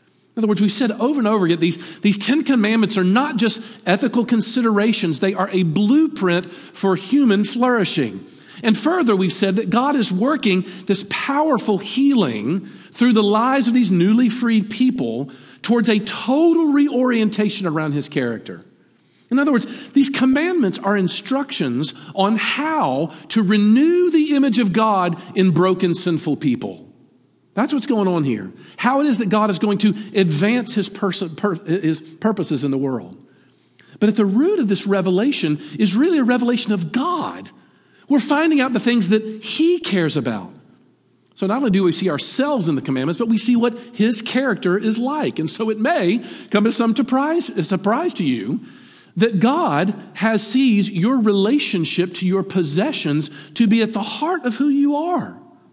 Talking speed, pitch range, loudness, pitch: 175 wpm, 185-255 Hz, -18 LUFS, 215 Hz